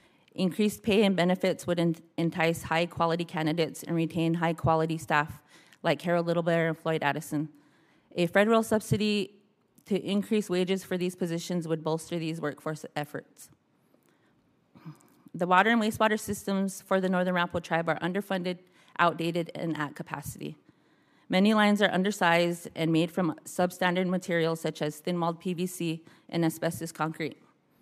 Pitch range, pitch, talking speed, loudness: 160-185 Hz, 170 Hz, 145 wpm, -28 LUFS